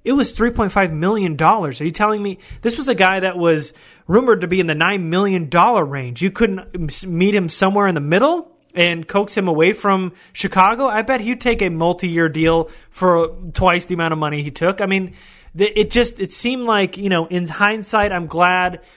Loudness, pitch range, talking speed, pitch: -17 LUFS, 170-210 Hz, 210 wpm, 185 Hz